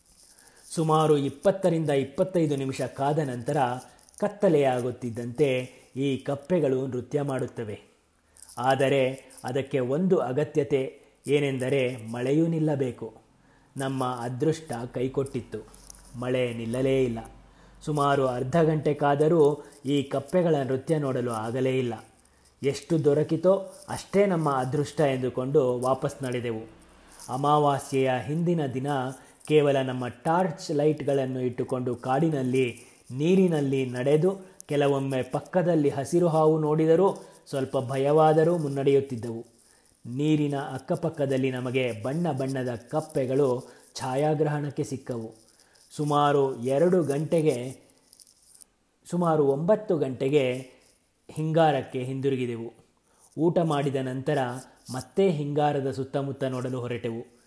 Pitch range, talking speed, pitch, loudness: 125-150 Hz, 90 wpm, 135 Hz, -26 LUFS